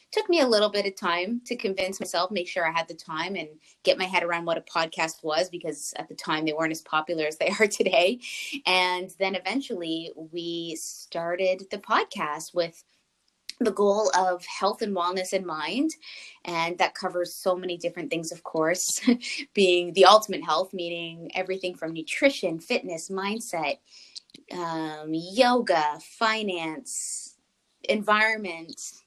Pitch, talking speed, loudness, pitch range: 180 Hz, 155 wpm, -26 LUFS, 165-200 Hz